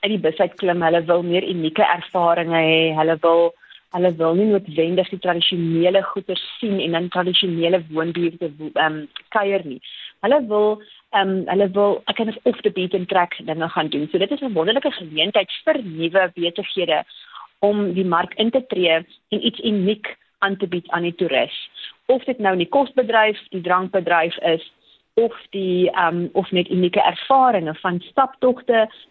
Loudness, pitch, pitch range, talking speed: -20 LUFS, 185 Hz, 170-210 Hz, 180 wpm